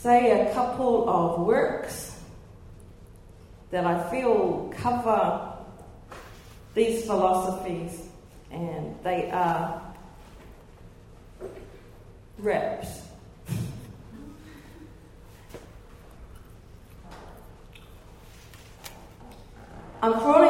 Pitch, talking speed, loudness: 175 Hz, 45 wpm, -26 LUFS